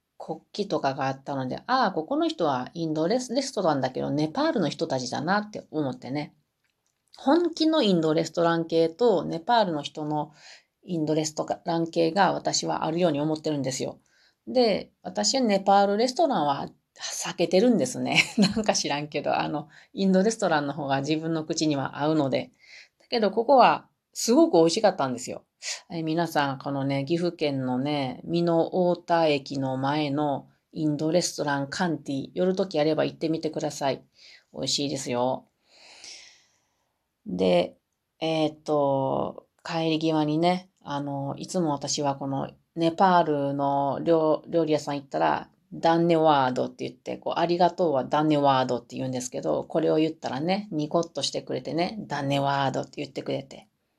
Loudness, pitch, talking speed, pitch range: -26 LUFS, 155 Hz, 350 characters per minute, 140-175 Hz